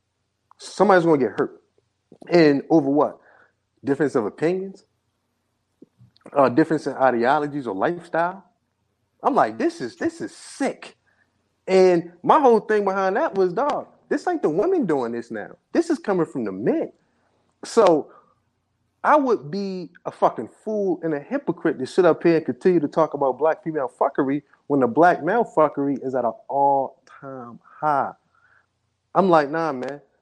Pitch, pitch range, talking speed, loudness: 160 Hz, 140-190 Hz, 160 wpm, -21 LUFS